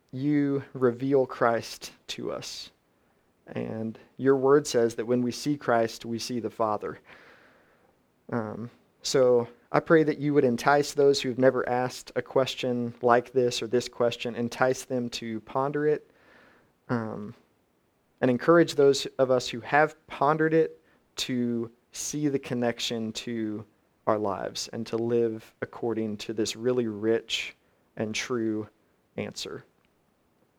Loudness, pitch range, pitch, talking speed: -27 LUFS, 115-135 Hz, 120 Hz, 140 wpm